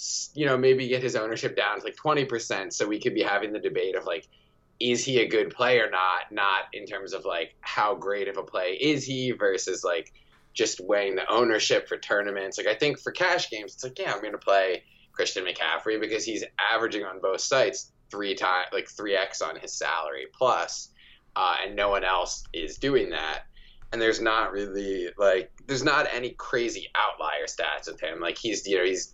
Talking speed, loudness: 210 wpm, -27 LUFS